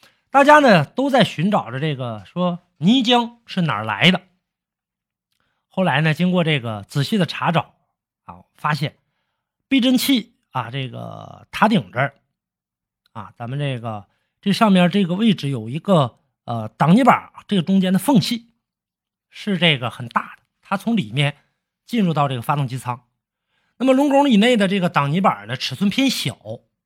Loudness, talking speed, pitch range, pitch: -19 LUFS, 235 characters per minute, 135-210 Hz, 175 Hz